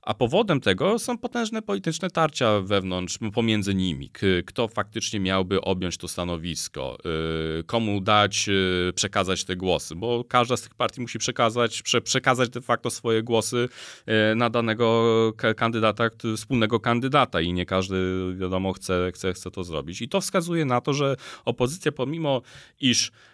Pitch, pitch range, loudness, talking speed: 115 Hz, 95-125 Hz, -24 LUFS, 145 wpm